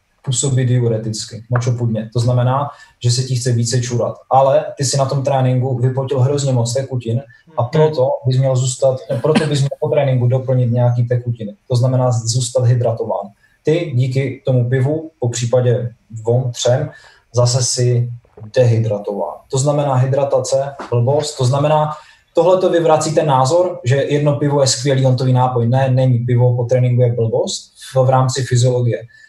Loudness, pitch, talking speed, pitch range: -16 LUFS, 130 Hz, 160 wpm, 120-140 Hz